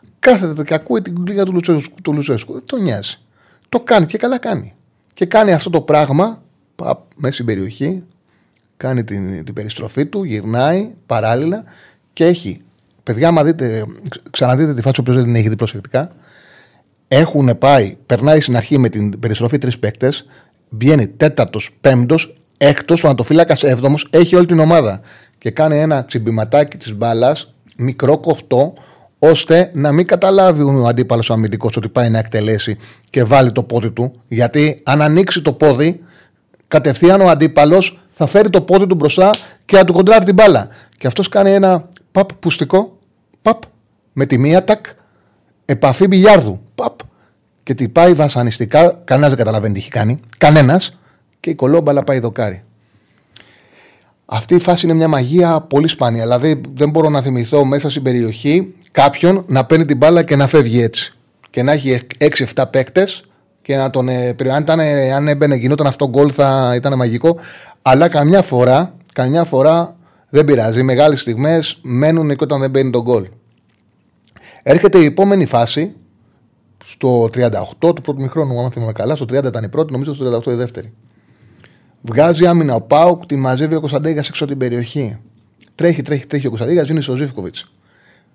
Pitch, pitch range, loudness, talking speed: 140 Hz, 120-165 Hz, -13 LUFS, 160 wpm